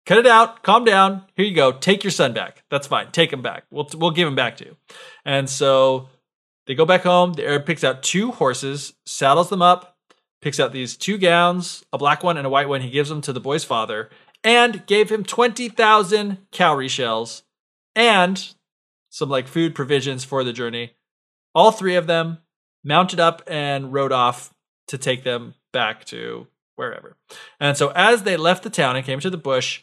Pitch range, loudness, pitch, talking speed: 135-190 Hz, -18 LUFS, 165 Hz, 200 wpm